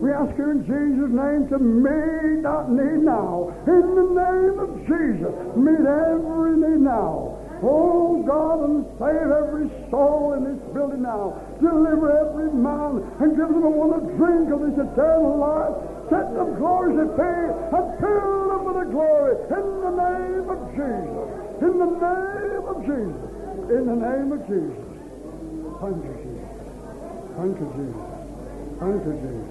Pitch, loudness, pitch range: 300 Hz, -21 LUFS, 275-335 Hz